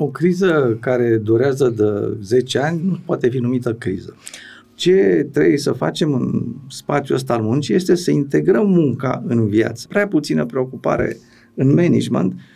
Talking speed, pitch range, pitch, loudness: 155 wpm, 115-175 Hz, 130 Hz, -18 LUFS